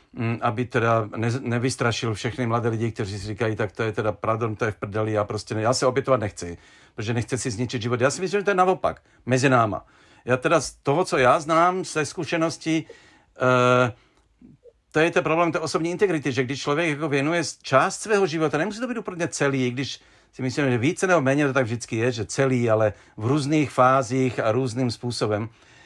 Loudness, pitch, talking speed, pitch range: -23 LUFS, 130 Hz, 210 wpm, 115-155 Hz